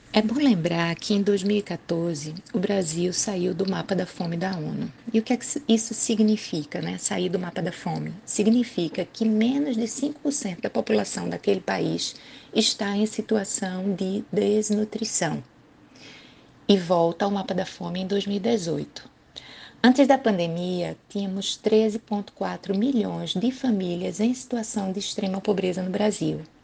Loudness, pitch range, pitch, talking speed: -25 LUFS, 180-220 Hz, 200 Hz, 145 wpm